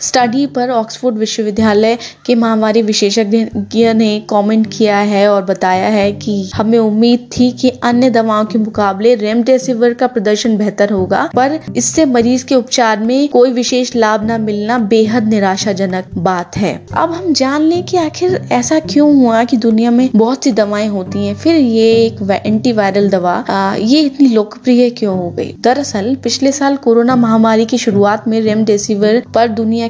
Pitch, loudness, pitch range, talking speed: 225 Hz, -12 LUFS, 210-250 Hz, 170 wpm